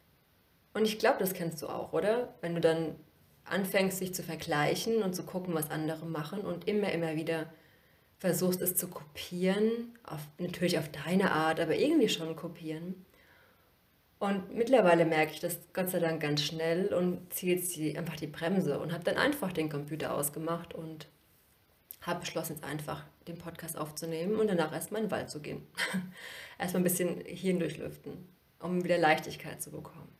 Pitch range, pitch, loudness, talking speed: 160-185 Hz, 170 Hz, -32 LUFS, 175 wpm